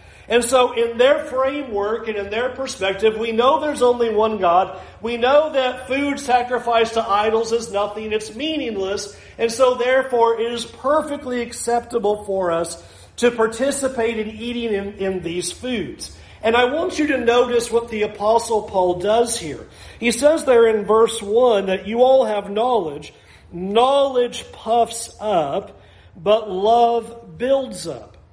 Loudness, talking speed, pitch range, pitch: -19 LUFS, 155 wpm, 215-250 Hz, 230 Hz